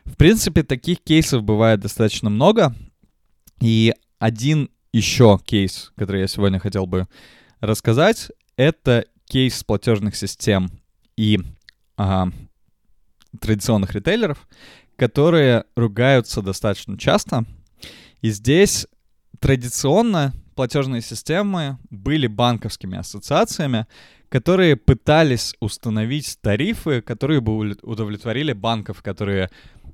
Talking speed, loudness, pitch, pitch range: 90 wpm, -19 LUFS, 115 Hz, 105-140 Hz